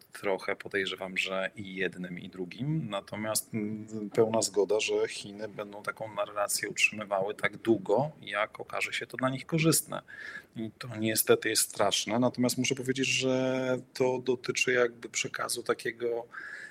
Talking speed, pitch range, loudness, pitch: 140 wpm, 105-130 Hz, -30 LUFS, 120 Hz